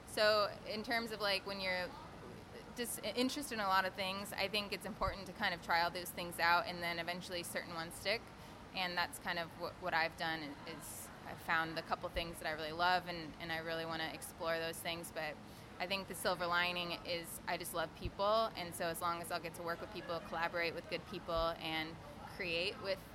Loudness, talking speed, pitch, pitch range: -39 LUFS, 230 wpm, 175 Hz, 165-190 Hz